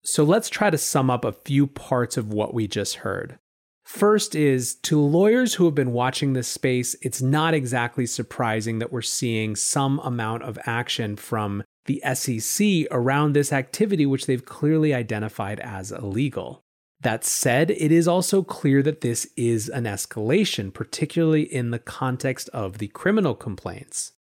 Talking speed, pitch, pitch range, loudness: 165 wpm, 130 Hz, 115-155 Hz, -23 LUFS